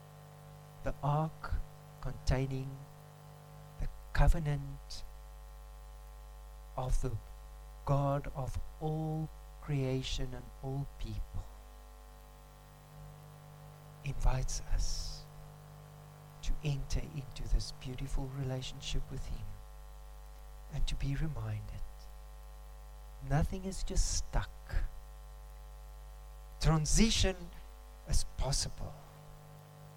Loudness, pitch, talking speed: -38 LUFS, 135 Hz, 70 wpm